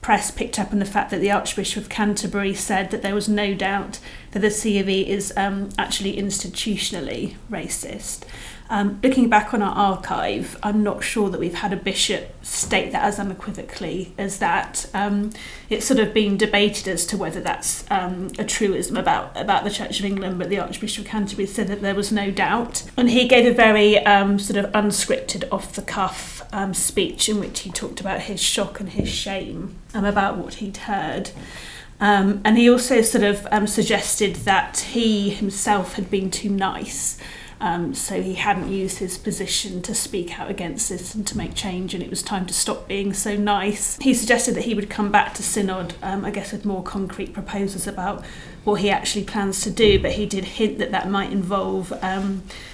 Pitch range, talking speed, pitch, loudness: 195-210 Hz, 200 wpm, 200 Hz, -21 LUFS